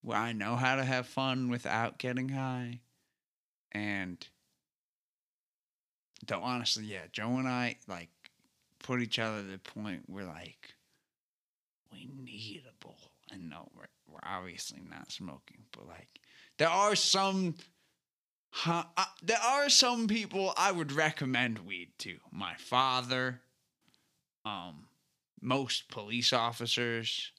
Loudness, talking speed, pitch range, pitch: -32 LUFS, 130 wpm, 115-150 Hz, 125 Hz